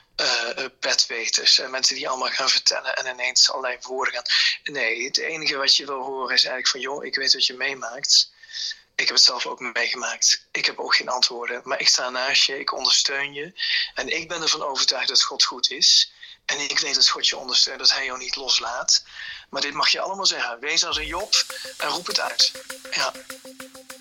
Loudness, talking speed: -20 LUFS, 205 wpm